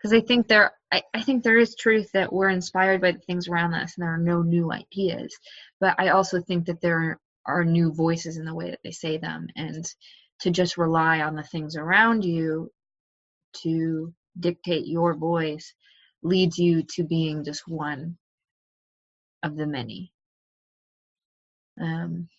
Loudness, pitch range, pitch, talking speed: -24 LUFS, 160-185 Hz, 170 Hz, 170 wpm